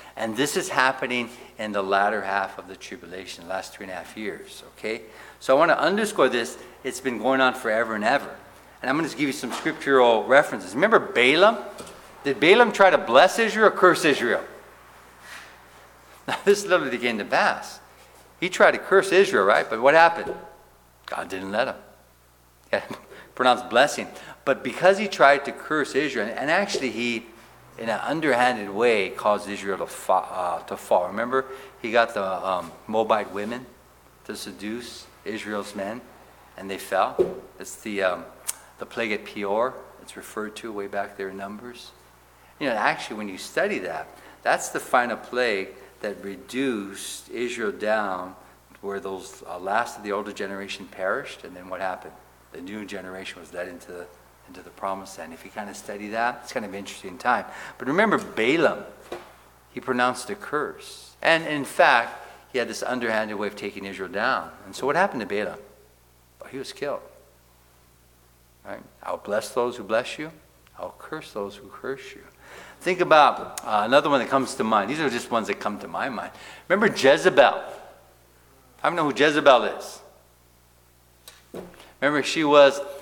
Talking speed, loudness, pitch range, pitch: 180 wpm, -23 LUFS, 95-125 Hz, 105 Hz